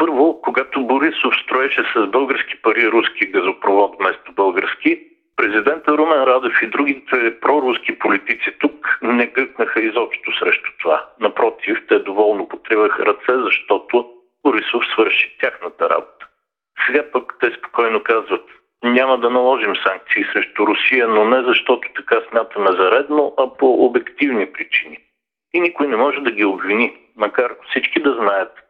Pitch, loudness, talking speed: 155 Hz, -17 LUFS, 140 wpm